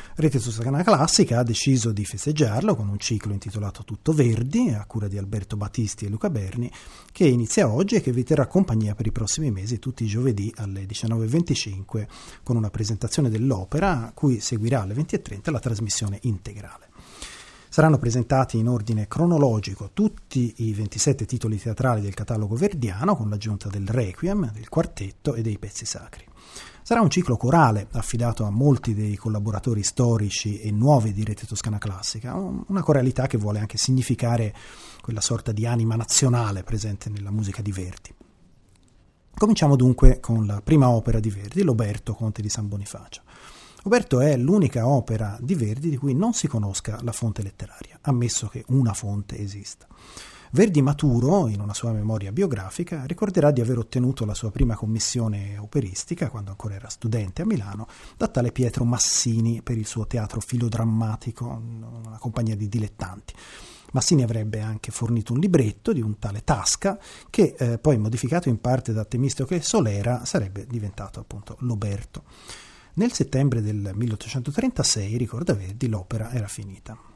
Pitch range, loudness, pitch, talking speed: 105-130 Hz, -24 LUFS, 115 Hz, 160 wpm